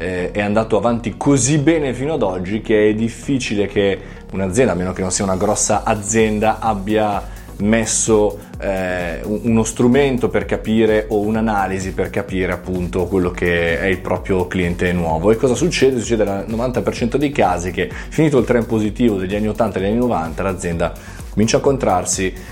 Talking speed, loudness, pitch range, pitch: 170 wpm, -18 LUFS, 90-110 Hz, 105 Hz